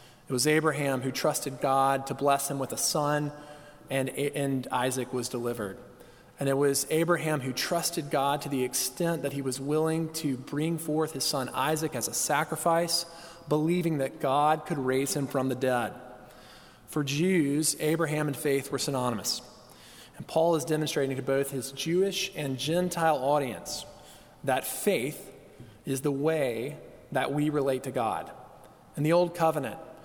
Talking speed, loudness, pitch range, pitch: 160 wpm, -29 LUFS, 130-155 Hz, 145 Hz